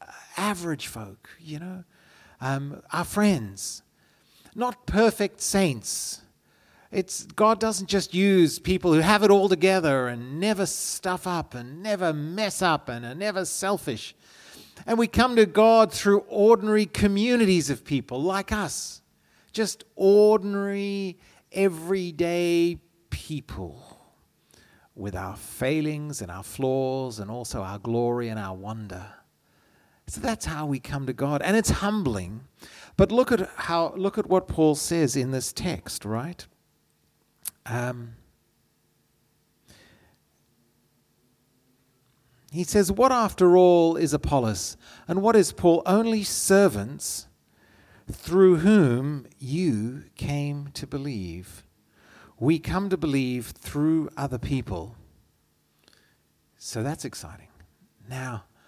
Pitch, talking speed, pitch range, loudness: 155 Hz, 120 wpm, 120-195 Hz, -24 LUFS